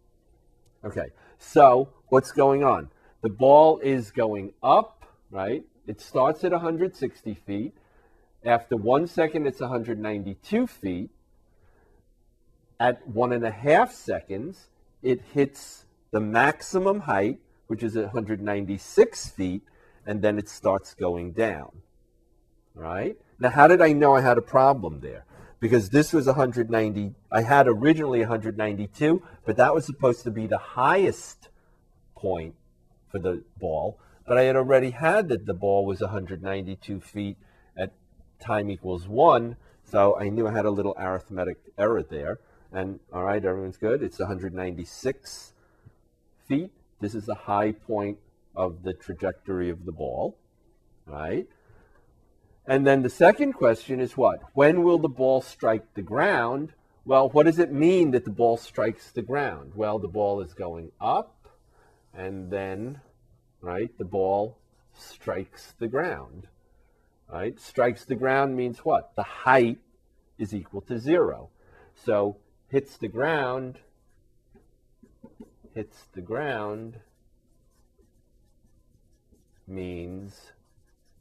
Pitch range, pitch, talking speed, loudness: 100-130 Hz, 110 Hz, 130 wpm, -24 LUFS